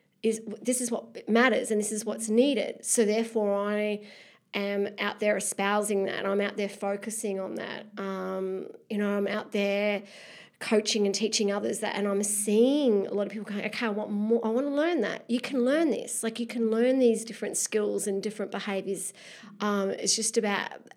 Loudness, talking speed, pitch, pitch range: -28 LUFS, 200 wpm, 210 Hz, 200-225 Hz